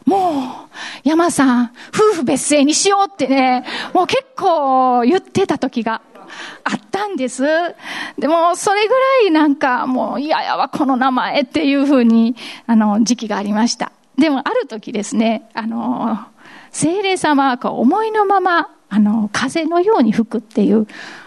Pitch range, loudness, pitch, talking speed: 240-345 Hz, -16 LUFS, 280 Hz, 295 characters per minute